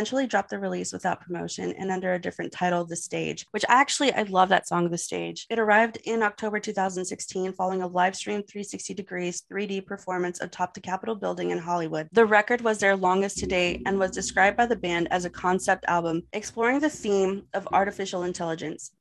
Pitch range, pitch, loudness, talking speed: 175-205 Hz, 190 Hz, -26 LUFS, 200 wpm